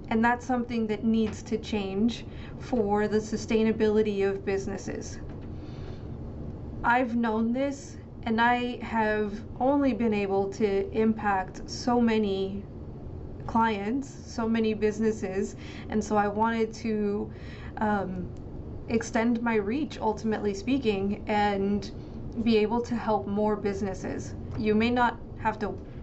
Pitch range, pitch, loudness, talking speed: 205-230 Hz, 220 Hz, -28 LUFS, 120 wpm